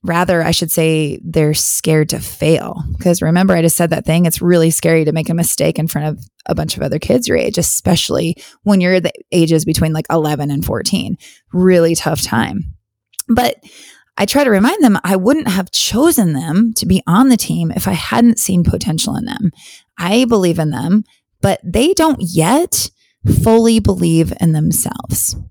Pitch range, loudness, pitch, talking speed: 160-205 Hz, -14 LUFS, 175 Hz, 190 wpm